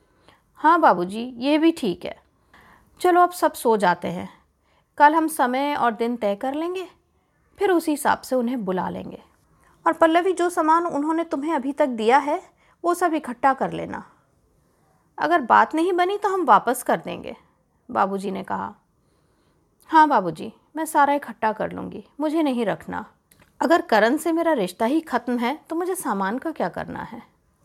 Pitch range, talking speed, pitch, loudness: 240-330 Hz, 175 wpm, 300 Hz, -21 LUFS